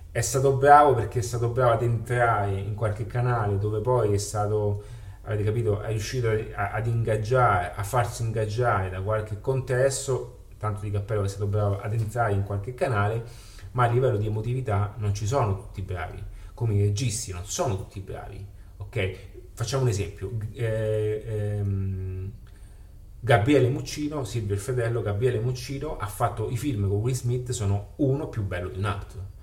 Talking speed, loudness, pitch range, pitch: 175 wpm, -26 LUFS, 100-120 Hz, 110 Hz